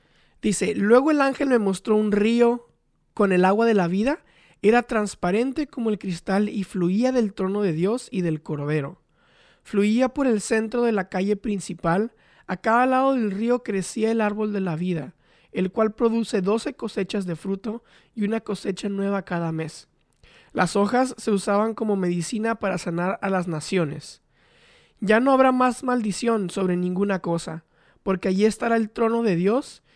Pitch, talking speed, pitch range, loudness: 210 Hz, 170 wpm, 185-230 Hz, -23 LUFS